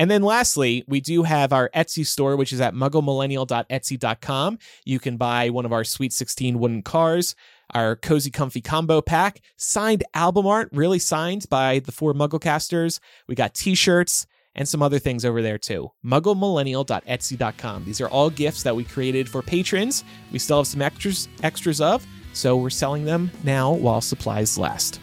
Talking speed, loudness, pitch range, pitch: 175 wpm, -22 LUFS, 125-160 Hz, 140 Hz